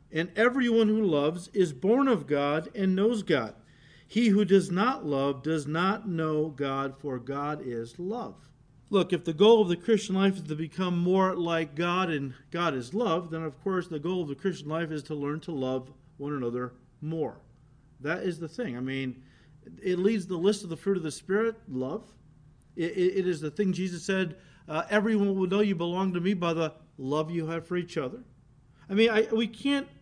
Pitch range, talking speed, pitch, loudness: 145-195 Hz, 205 wpm, 165 Hz, -28 LUFS